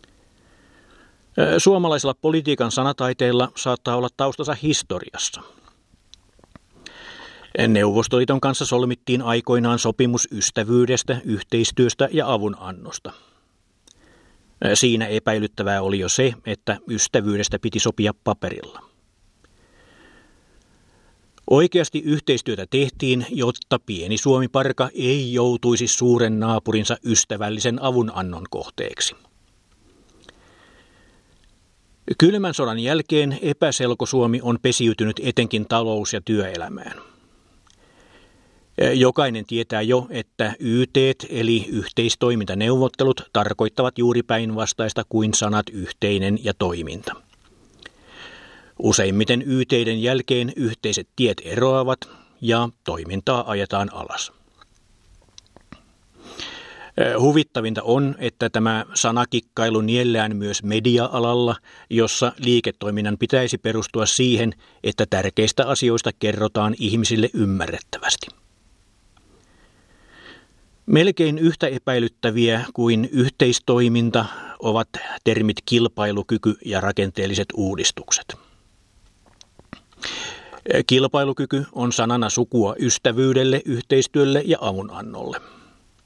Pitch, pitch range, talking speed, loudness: 115 Hz, 105-125 Hz, 80 wpm, -20 LUFS